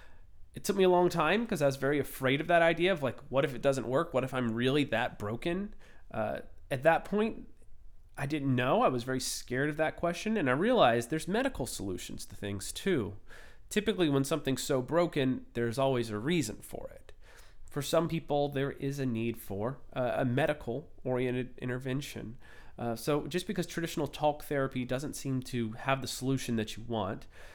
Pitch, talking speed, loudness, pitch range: 135 Hz, 195 wpm, -32 LUFS, 120-160 Hz